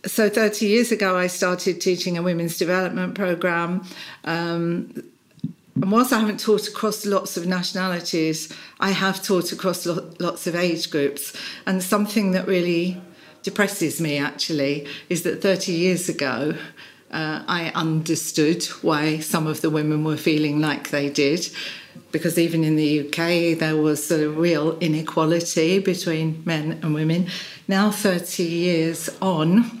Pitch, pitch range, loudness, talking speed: 170 Hz, 160-185 Hz, -22 LUFS, 150 wpm